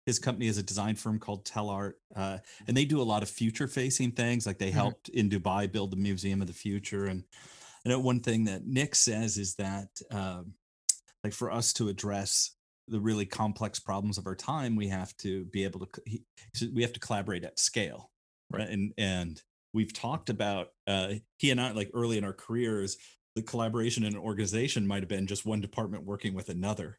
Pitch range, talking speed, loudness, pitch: 100-115 Hz, 205 wpm, -32 LUFS, 105 Hz